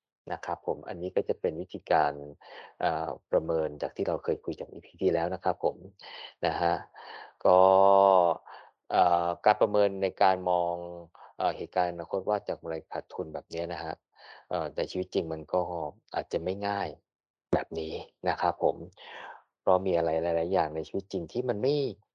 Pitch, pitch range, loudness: 85 Hz, 80-95 Hz, -29 LUFS